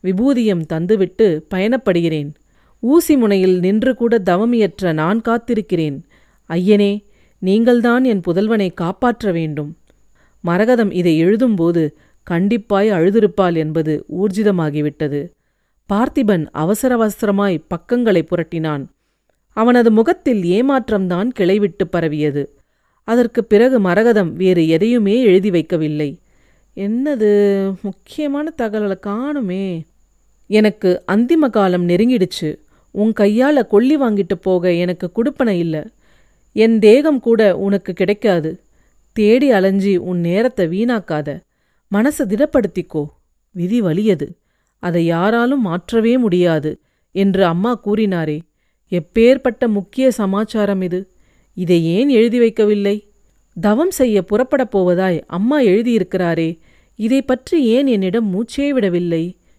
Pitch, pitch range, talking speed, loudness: 200 Hz, 175-230 Hz, 95 wpm, -16 LUFS